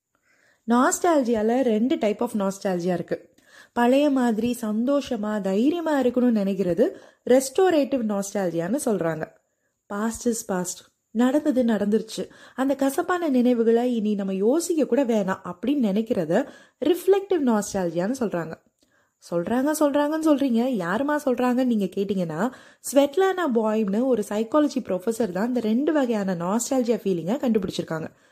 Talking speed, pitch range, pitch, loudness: 100 wpm, 205-275 Hz, 235 Hz, -23 LUFS